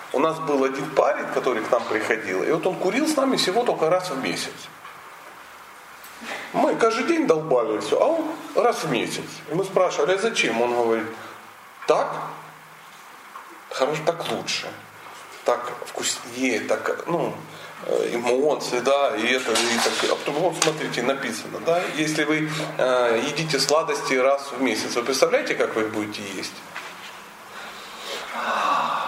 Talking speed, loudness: 140 wpm, -23 LUFS